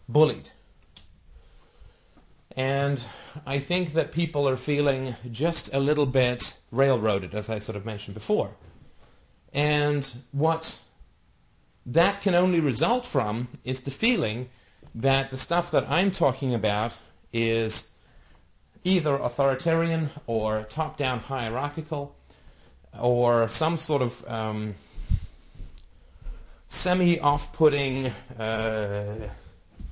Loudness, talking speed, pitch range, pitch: -26 LUFS, 100 wpm, 105-145 Hz, 125 Hz